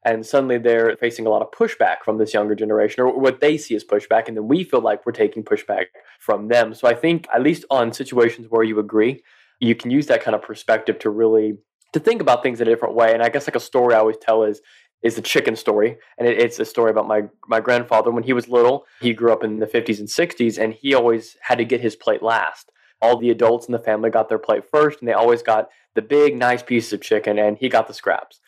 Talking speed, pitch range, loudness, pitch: 260 wpm, 110-125 Hz, -19 LUFS, 115 Hz